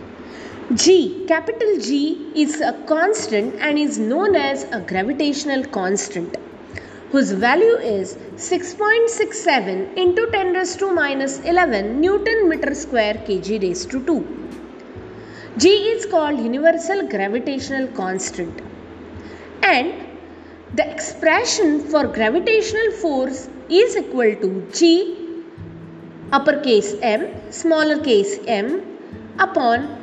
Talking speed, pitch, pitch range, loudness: 105 wpm, 320 Hz, 265-365 Hz, -18 LUFS